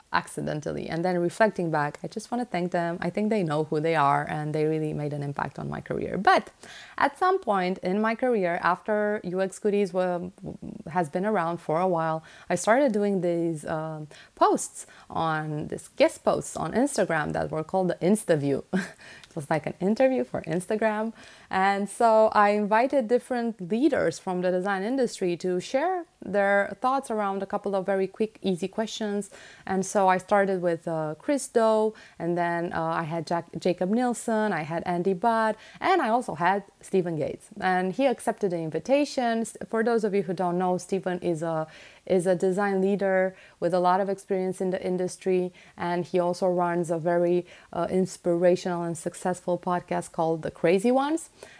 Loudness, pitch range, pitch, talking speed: -26 LUFS, 175-215 Hz, 185 Hz, 185 wpm